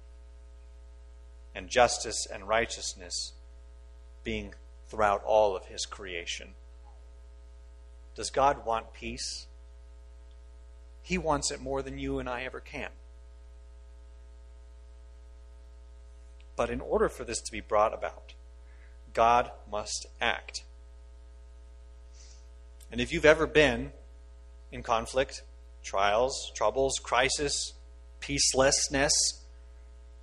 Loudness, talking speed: -29 LUFS, 95 wpm